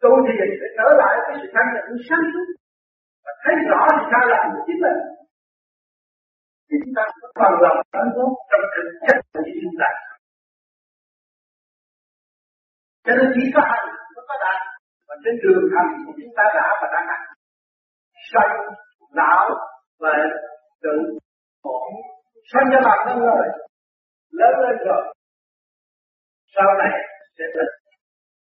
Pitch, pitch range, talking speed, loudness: 270 Hz, 215-335 Hz, 120 wpm, -18 LUFS